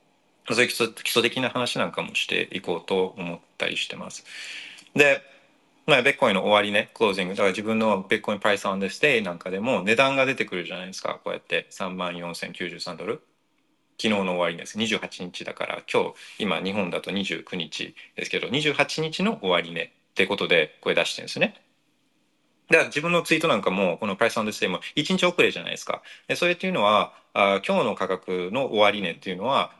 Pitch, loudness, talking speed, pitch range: 110 Hz, -24 LUFS, 390 characters per minute, 95-150 Hz